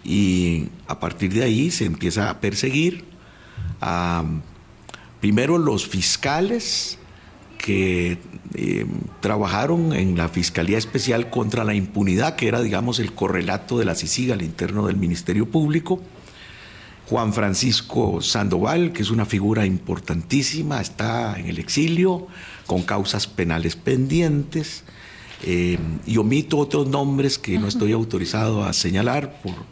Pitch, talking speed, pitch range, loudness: 105 Hz, 130 wpm, 90-125 Hz, -22 LUFS